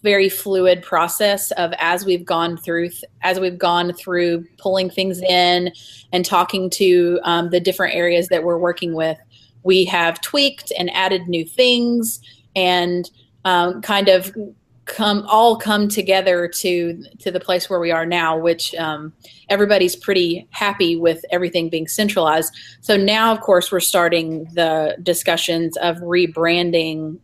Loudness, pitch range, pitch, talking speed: -18 LUFS, 170-190 Hz, 175 Hz, 150 wpm